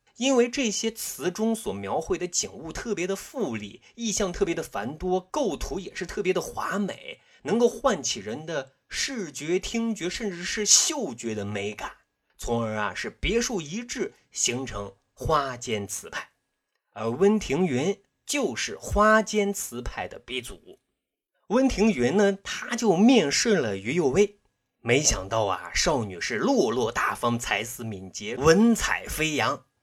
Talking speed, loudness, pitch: 220 characters per minute, -26 LUFS, 195 Hz